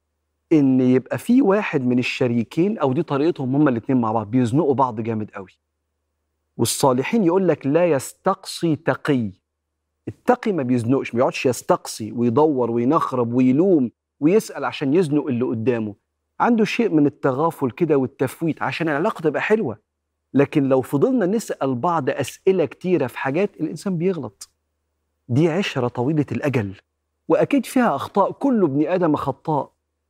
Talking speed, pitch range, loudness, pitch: 140 wpm, 115-165 Hz, -20 LUFS, 135 Hz